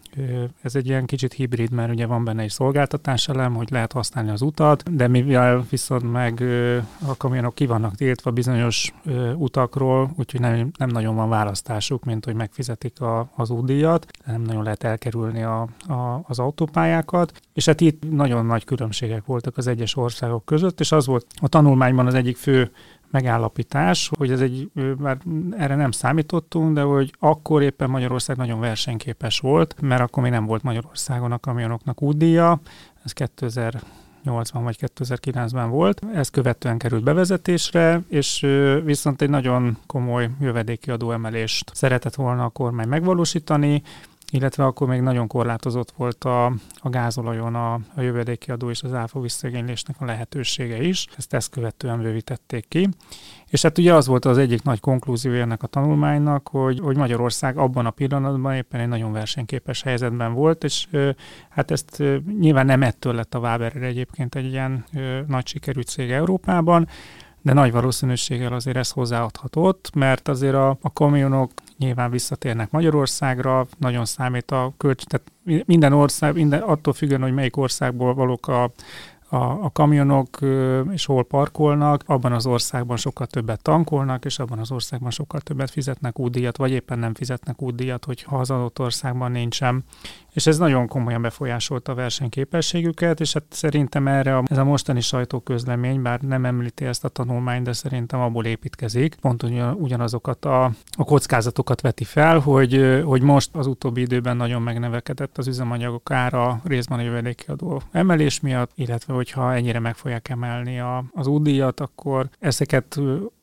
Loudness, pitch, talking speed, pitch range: -21 LUFS, 130 Hz, 160 wpm, 120-145 Hz